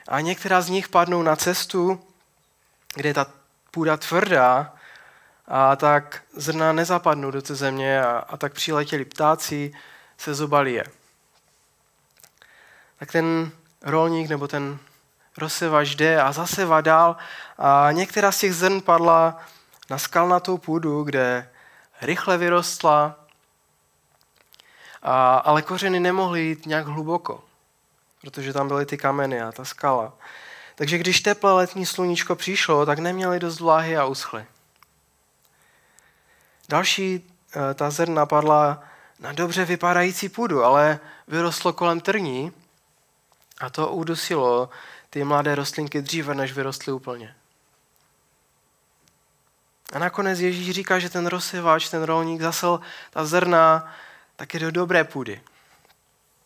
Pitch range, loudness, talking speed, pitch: 145-175 Hz, -21 LUFS, 120 wpm, 160 Hz